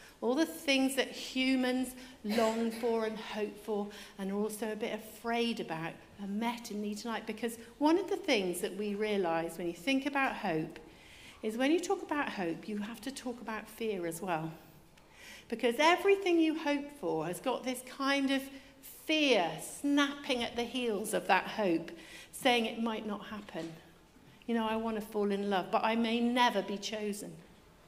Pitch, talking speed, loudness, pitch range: 225 Hz, 185 wpm, -33 LUFS, 205-255 Hz